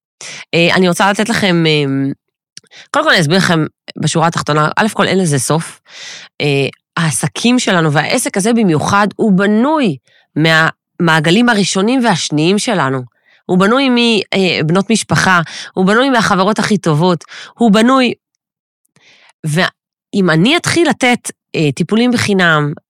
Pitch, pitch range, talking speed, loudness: 185 Hz, 160-220 Hz, 125 wpm, -12 LUFS